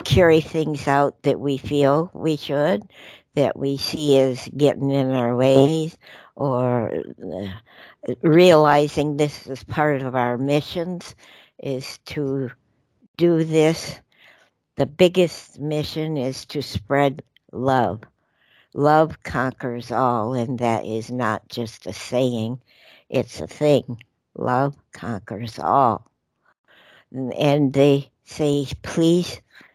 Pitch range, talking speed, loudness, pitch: 125-150 Hz, 115 wpm, -21 LUFS, 140 Hz